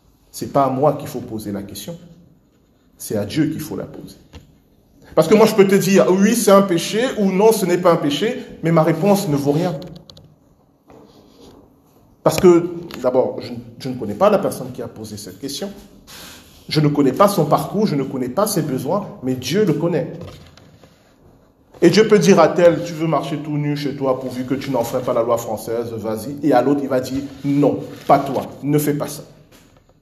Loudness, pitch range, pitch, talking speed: -17 LUFS, 130-175 Hz, 150 Hz, 215 wpm